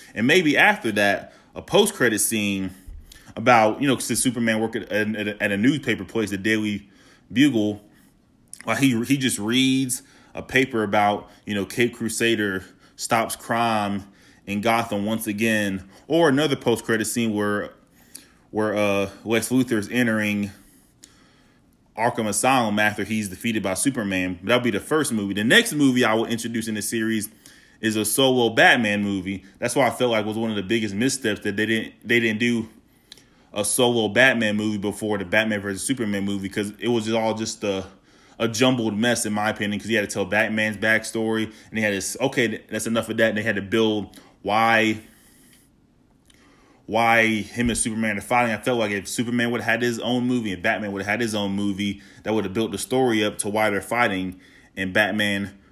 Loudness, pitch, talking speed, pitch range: -22 LUFS, 110 Hz, 190 wpm, 105-115 Hz